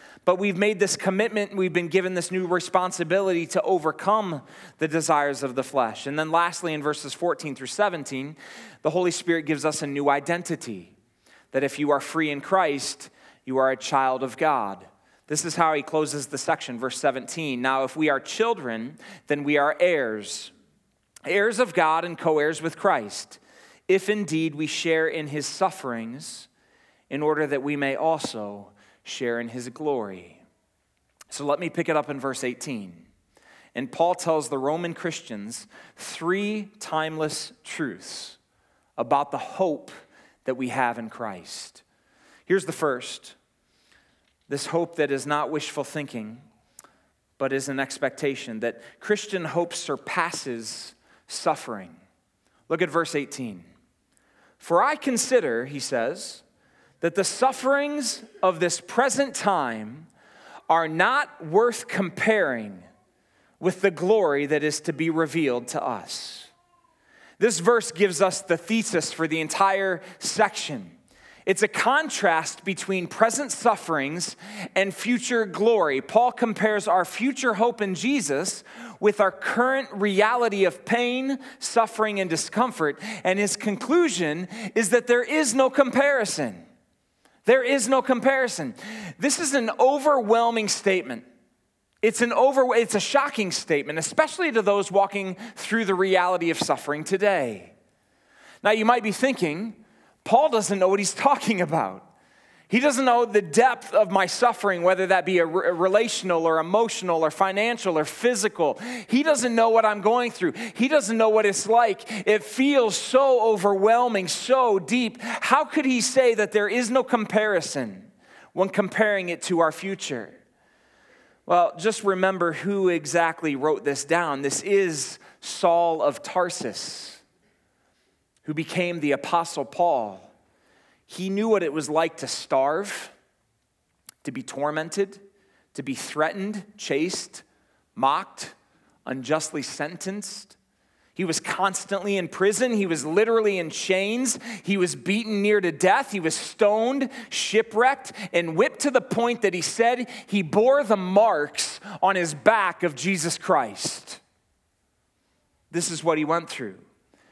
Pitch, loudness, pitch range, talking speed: 185 Hz, -24 LUFS, 155-225 Hz, 145 wpm